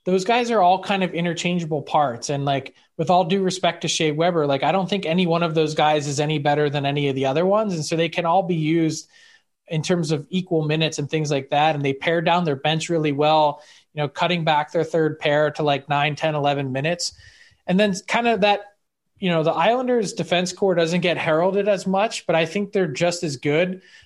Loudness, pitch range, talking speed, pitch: -21 LUFS, 150-185 Hz, 235 wpm, 165 Hz